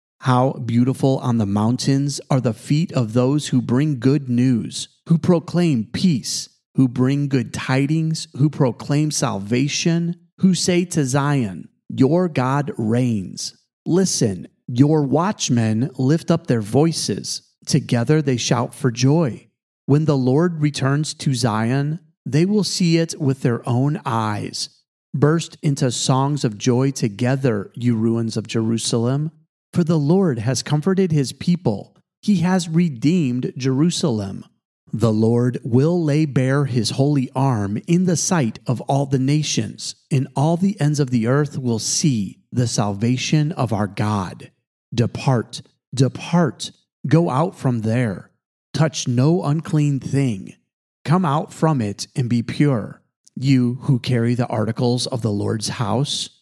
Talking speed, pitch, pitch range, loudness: 140 wpm, 135 Hz, 125-155 Hz, -20 LUFS